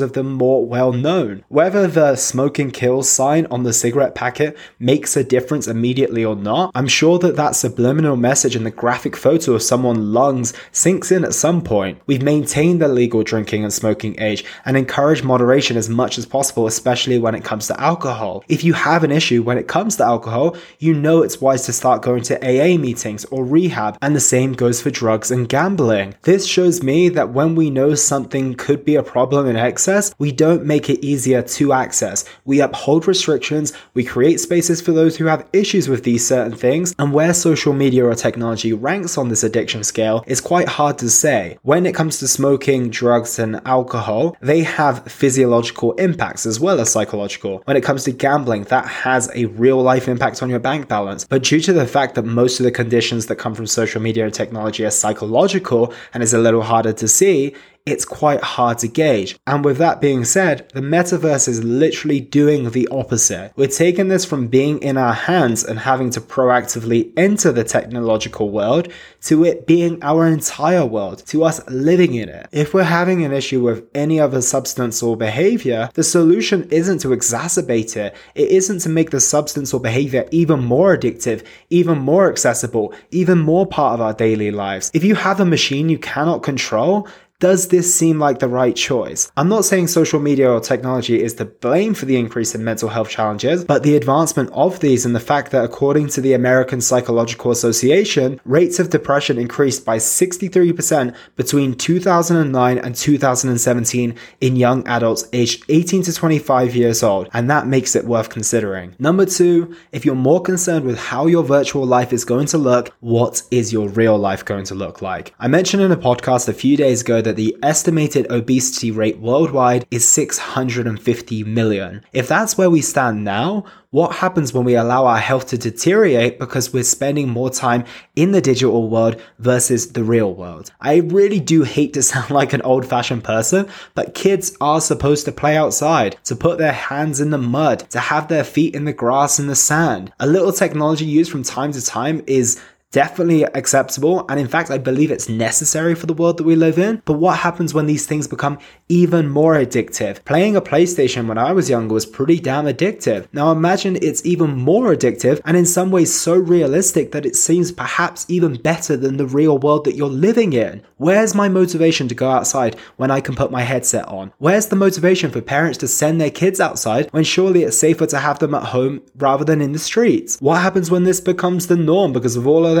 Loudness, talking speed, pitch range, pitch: -16 LUFS, 200 wpm, 120-165 Hz, 135 Hz